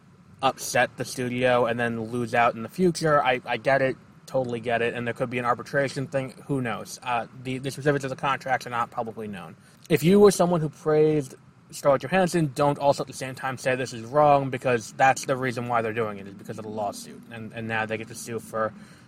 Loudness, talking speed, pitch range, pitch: -25 LUFS, 240 wpm, 115-145 Hz, 130 Hz